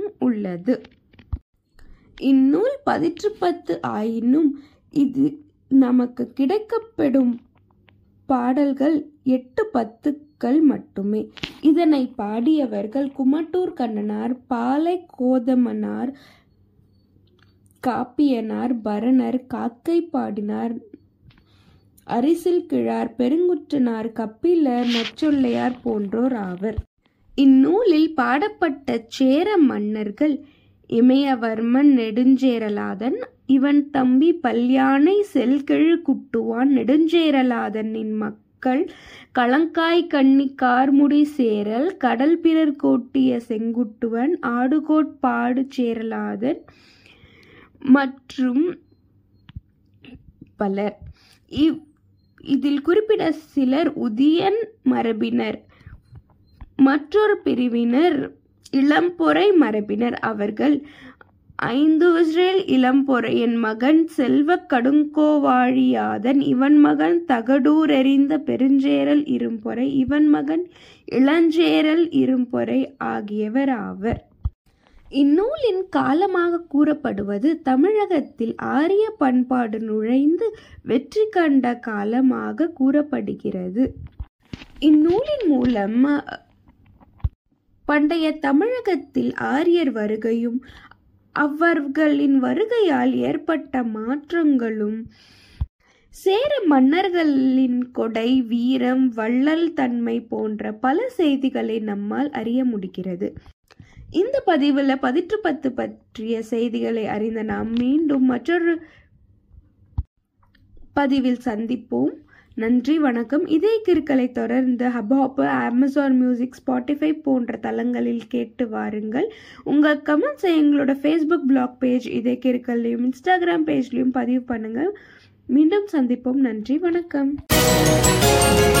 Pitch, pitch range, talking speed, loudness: 265 Hz, 235-305 Hz, 70 wpm, -20 LUFS